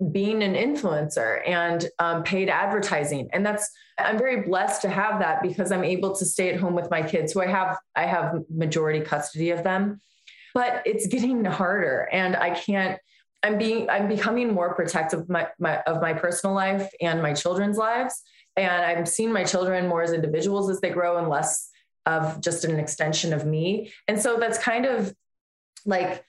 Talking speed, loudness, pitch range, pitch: 190 wpm, -25 LUFS, 170-205 Hz, 185 Hz